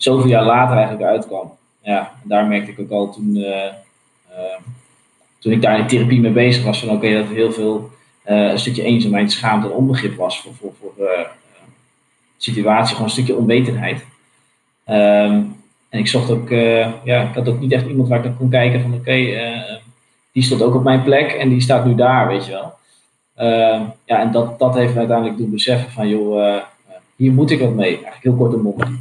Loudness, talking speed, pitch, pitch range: -16 LUFS, 220 wpm, 120 Hz, 110-125 Hz